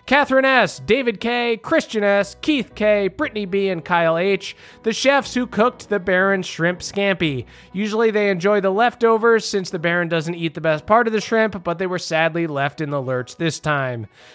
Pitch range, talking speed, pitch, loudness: 170-225 Hz, 195 wpm, 200 Hz, -19 LUFS